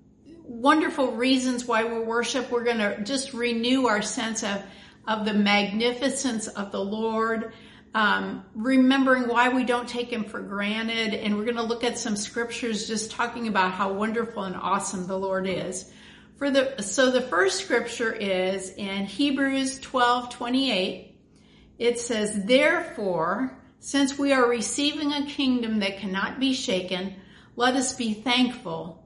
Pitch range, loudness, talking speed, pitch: 205-255 Hz, -25 LUFS, 155 wpm, 235 Hz